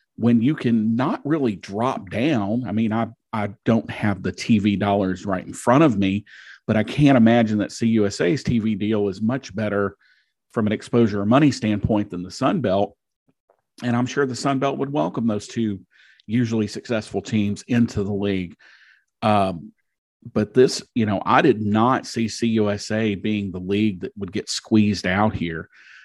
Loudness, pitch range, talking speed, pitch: -21 LUFS, 100-120 Hz, 175 wpm, 110 Hz